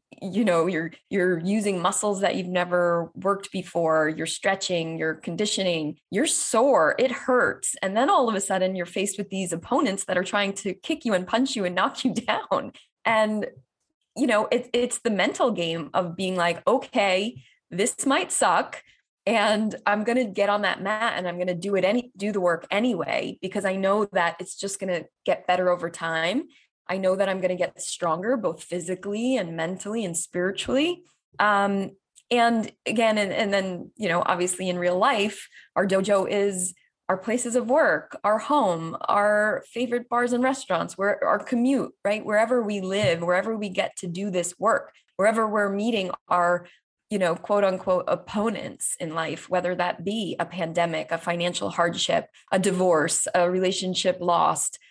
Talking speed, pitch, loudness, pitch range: 185 wpm, 195 Hz, -24 LUFS, 180-220 Hz